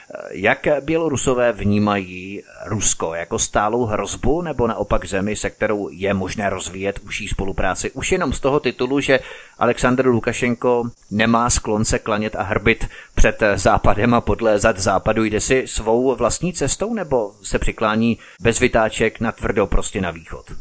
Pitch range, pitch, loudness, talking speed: 100-125 Hz, 110 Hz, -19 LUFS, 150 wpm